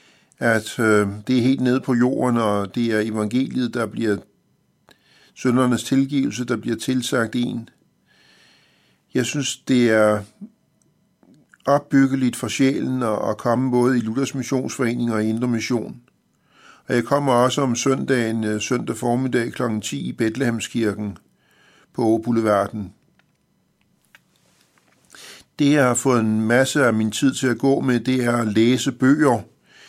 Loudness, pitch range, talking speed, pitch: -20 LUFS, 110-130 Hz, 140 wpm, 120 Hz